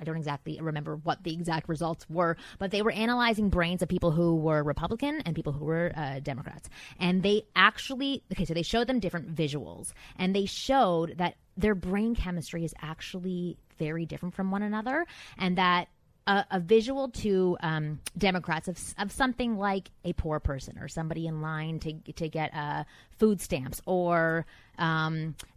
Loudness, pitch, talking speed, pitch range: -30 LUFS, 170 Hz, 180 wpm, 160-195 Hz